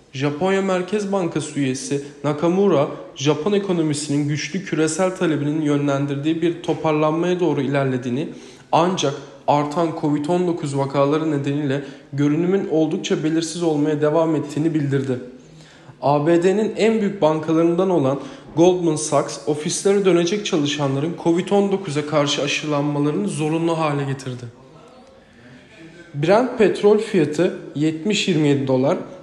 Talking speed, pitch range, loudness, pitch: 100 wpm, 145-175 Hz, -20 LUFS, 155 Hz